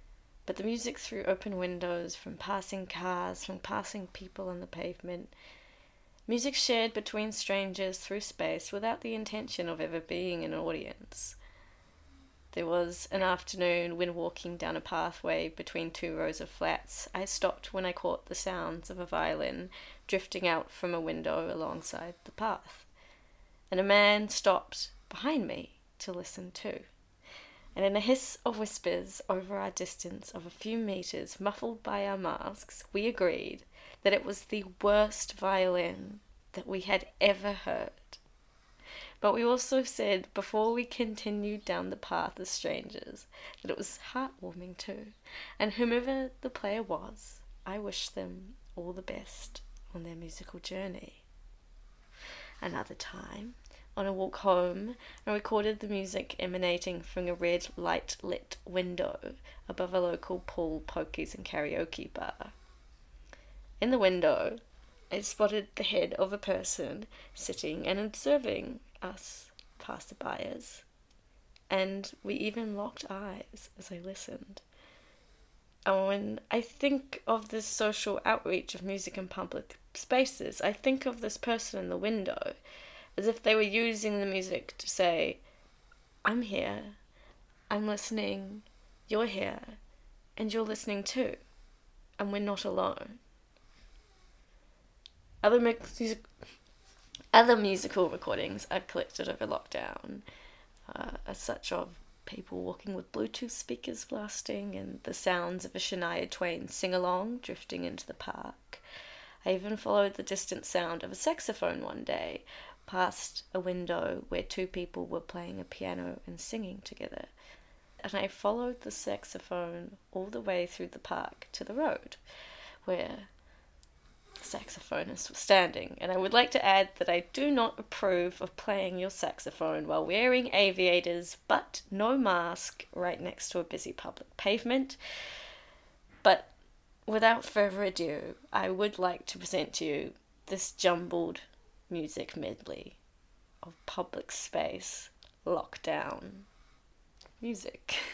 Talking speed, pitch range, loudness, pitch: 140 wpm, 175-215 Hz, -33 LUFS, 195 Hz